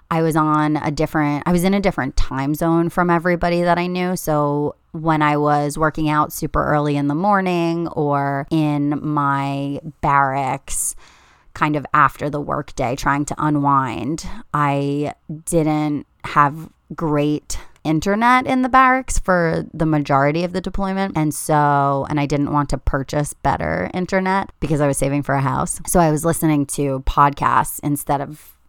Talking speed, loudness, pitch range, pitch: 165 wpm, -19 LUFS, 145-170 Hz, 150 Hz